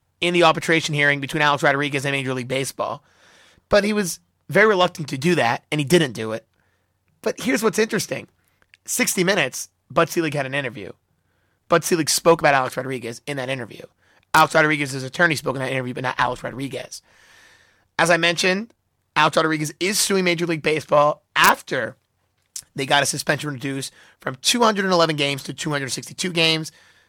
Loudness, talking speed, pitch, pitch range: -20 LUFS, 170 wpm, 150 Hz, 130-175 Hz